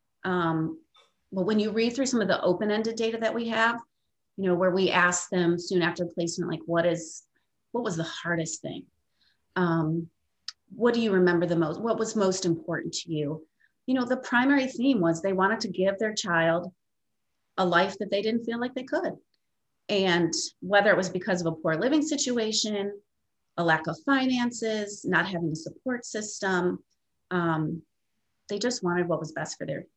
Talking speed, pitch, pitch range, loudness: 190 wpm, 190 Hz, 170-225 Hz, -27 LUFS